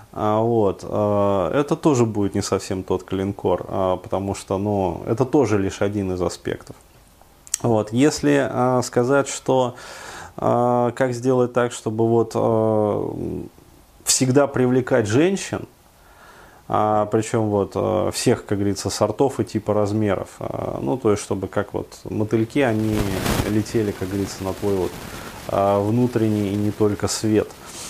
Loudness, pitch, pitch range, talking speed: -21 LUFS, 110 Hz, 100-125 Hz, 125 wpm